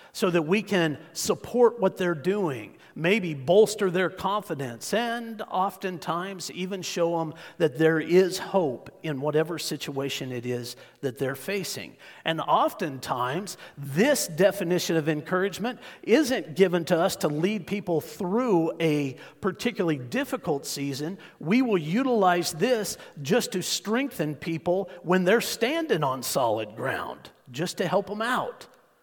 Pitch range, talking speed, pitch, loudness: 160-200 Hz, 135 wpm, 180 Hz, -26 LUFS